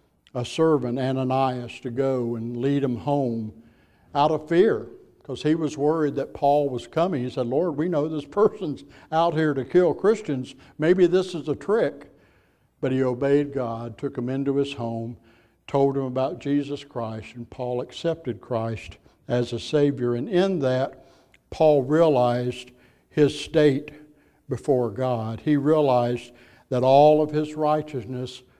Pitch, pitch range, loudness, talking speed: 135 Hz, 125-150 Hz, -24 LUFS, 155 wpm